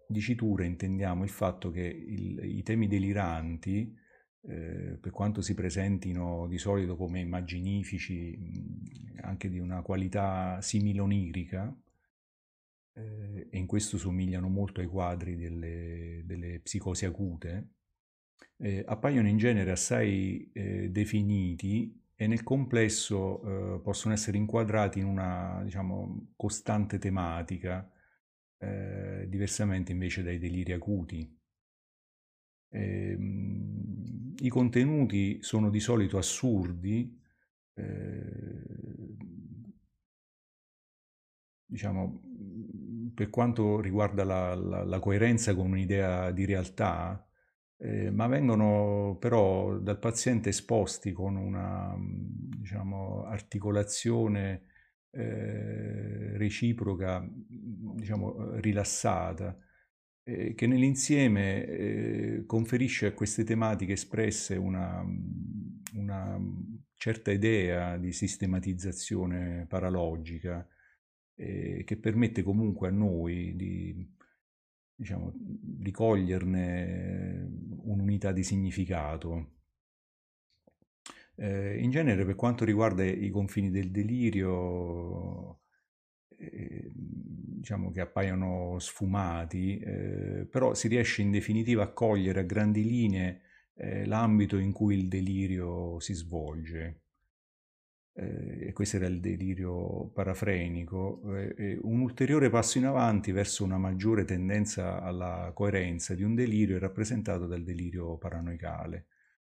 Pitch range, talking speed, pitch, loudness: 90-105 Hz, 105 wpm, 100 Hz, -32 LUFS